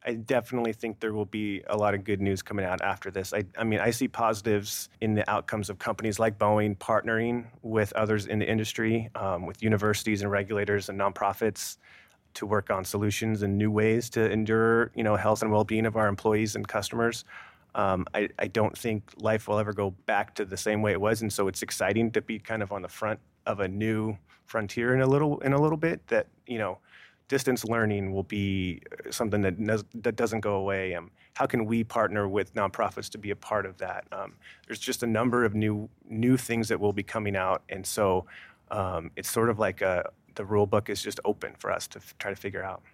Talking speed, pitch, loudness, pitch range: 220 wpm, 110 Hz, -28 LUFS, 100-115 Hz